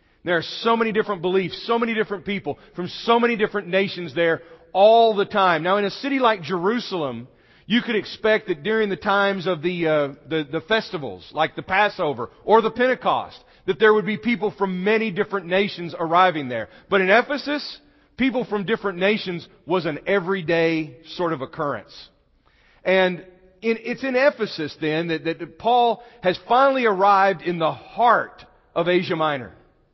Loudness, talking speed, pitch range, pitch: -21 LUFS, 170 wpm, 170-220 Hz, 190 Hz